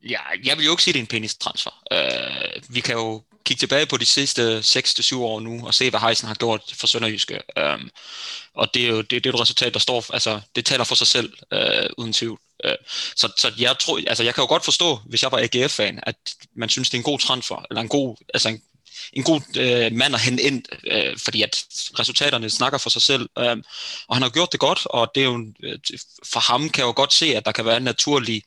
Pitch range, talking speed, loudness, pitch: 115-135 Hz, 255 wpm, -19 LUFS, 120 Hz